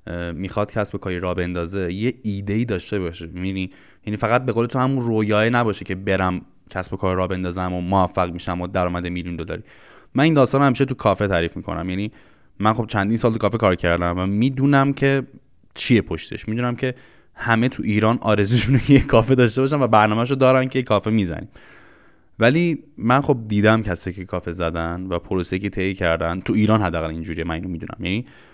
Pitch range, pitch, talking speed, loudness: 90-120 Hz, 100 Hz, 185 wpm, -21 LUFS